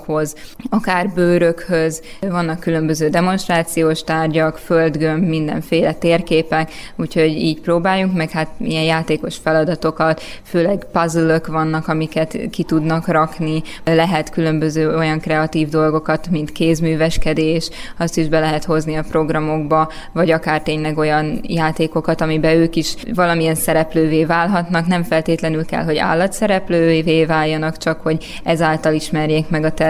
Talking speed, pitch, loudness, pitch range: 125 wpm, 160 Hz, -17 LUFS, 155-170 Hz